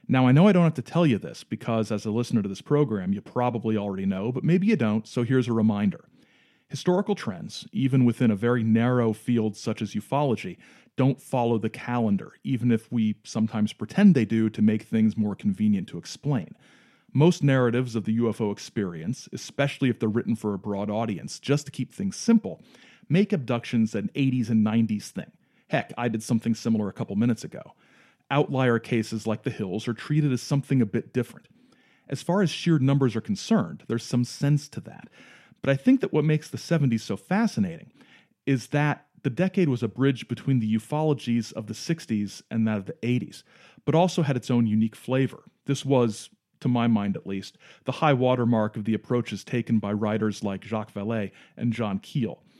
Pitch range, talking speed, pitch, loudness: 110-150 Hz, 200 wpm, 125 Hz, -25 LUFS